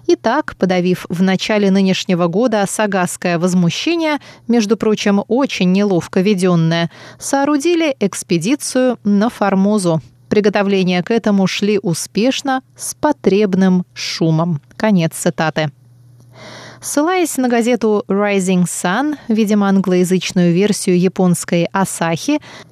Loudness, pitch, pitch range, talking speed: -15 LUFS, 195 Hz, 175-225 Hz, 100 wpm